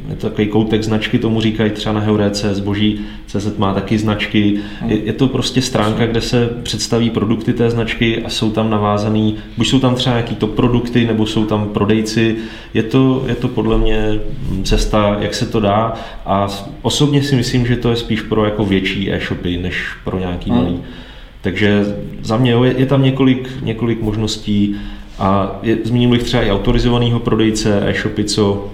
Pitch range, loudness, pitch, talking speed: 105-120 Hz, -16 LUFS, 110 Hz, 175 wpm